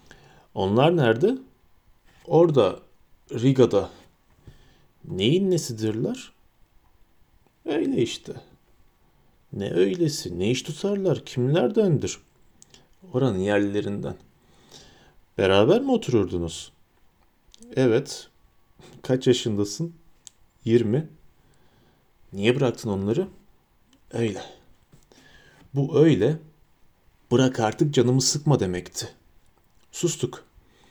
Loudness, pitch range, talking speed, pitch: -23 LUFS, 100-155 Hz, 70 wpm, 125 Hz